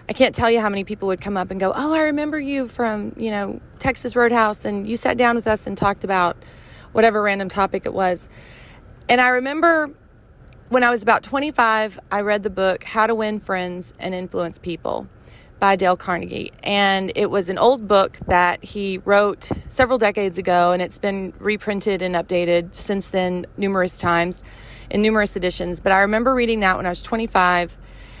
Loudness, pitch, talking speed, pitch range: -20 LUFS, 200 Hz, 195 wpm, 180-225 Hz